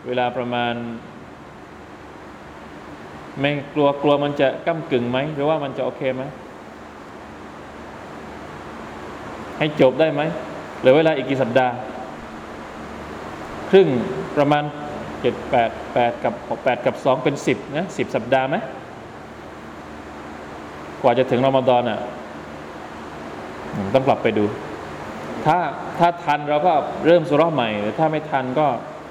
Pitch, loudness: 130 Hz, -20 LUFS